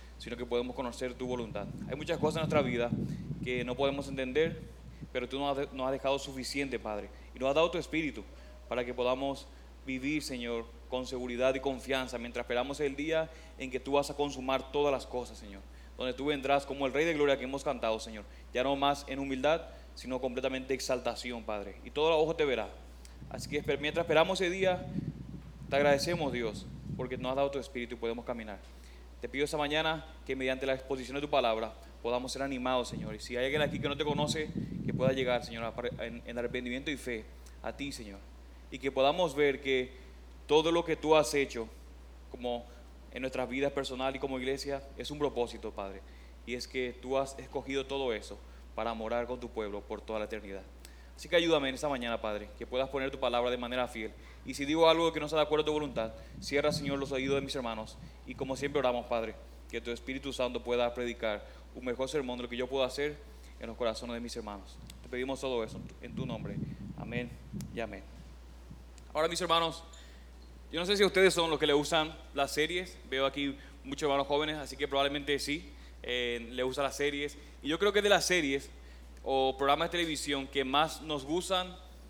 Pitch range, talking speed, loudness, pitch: 115-145 Hz, 210 wpm, -33 LUFS, 130 Hz